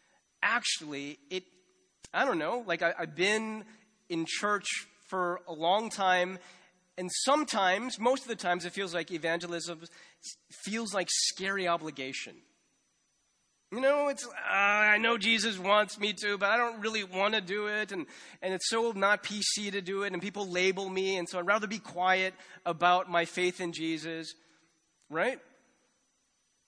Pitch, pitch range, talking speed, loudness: 190 Hz, 175-215 Hz, 160 wpm, -30 LUFS